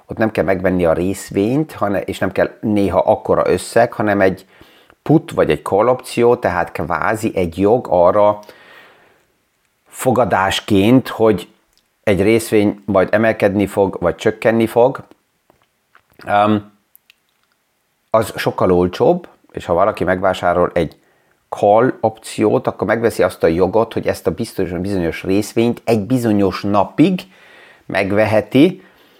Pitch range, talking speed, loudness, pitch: 95-110 Hz, 125 wpm, -16 LUFS, 105 Hz